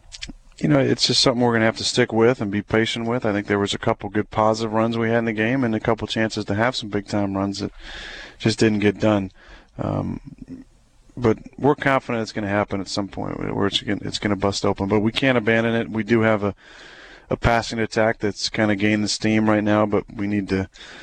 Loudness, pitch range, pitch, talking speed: -21 LUFS, 105-115 Hz, 110 Hz, 250 wpm